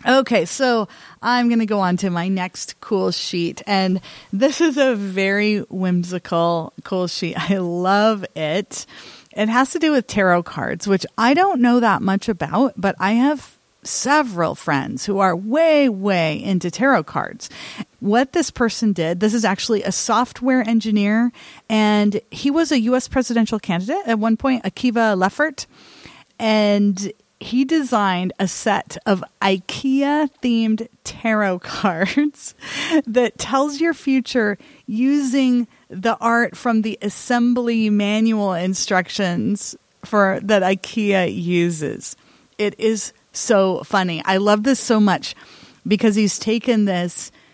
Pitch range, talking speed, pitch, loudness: 190-245 Hz, 140 wpm, 215 Hz, -19 LUFS